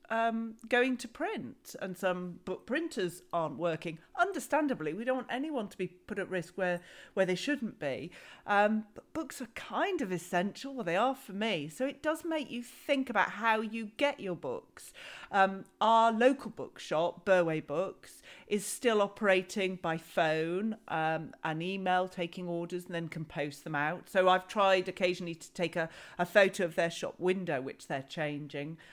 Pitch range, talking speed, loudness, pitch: 175-235 Hz, 180 wpm, -33 LUFS, 190 Hz